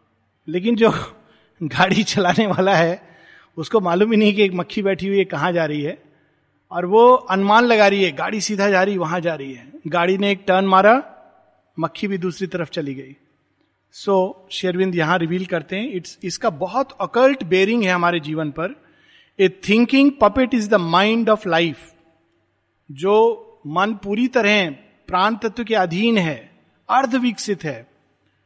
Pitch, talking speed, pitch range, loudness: 190 Hz, 170 wpm, 165-215 Hz, -18 LUFS